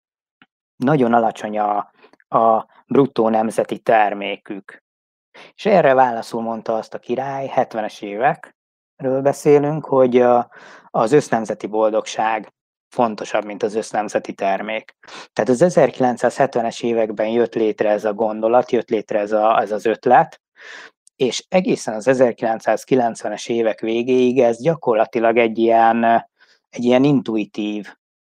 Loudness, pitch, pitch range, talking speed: -18 LUFS, 115 Hz, 110-125 Hz, 115 wpm